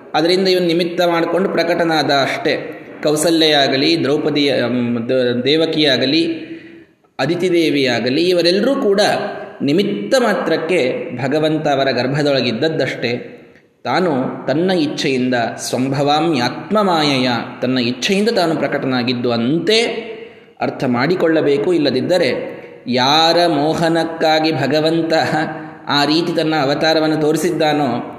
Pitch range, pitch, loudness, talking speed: 140-175 Hz, 155 Hz, -16 LUFS, 85 wpm